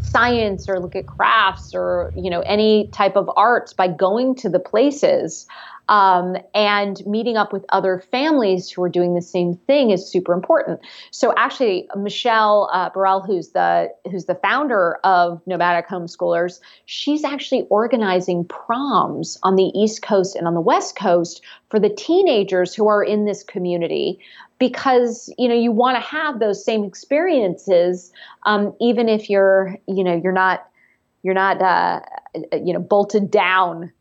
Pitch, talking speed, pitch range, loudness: 195 Hz, 160 wpm, 180-220 Hz, -18 LUFS